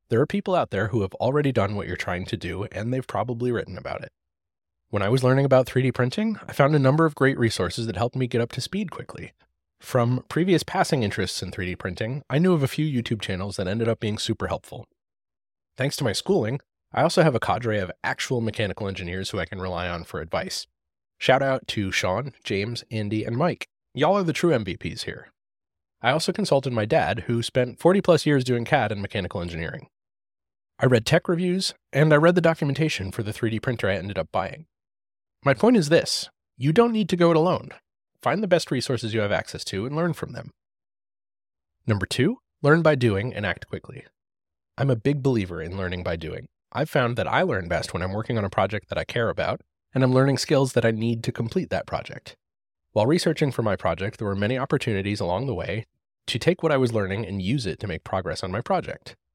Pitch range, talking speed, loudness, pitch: 100-140 Hz, 225 wpm, -24 LUFS, 120 Hz